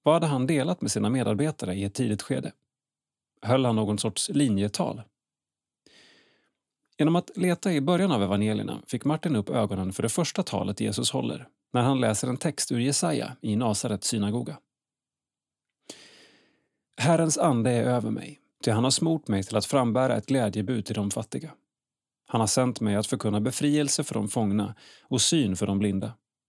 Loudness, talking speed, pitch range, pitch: -26 LUFS, 170 wpm, 105-140 Hz, 120 Hz